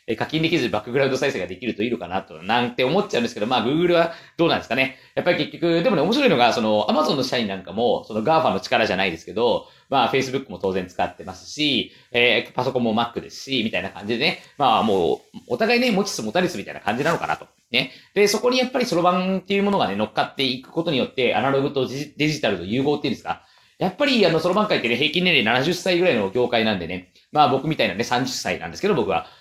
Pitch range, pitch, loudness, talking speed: 125-180 Hz, 150 Hz, -21 LUFS, 540 characters per minute